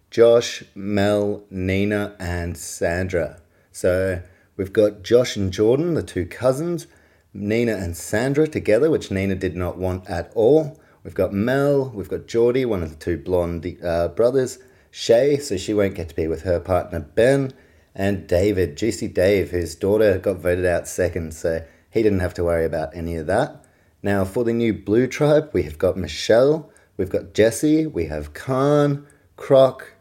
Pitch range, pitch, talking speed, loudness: 90-120 Hz, 100 Hz, 170 wpm, -21 LUFS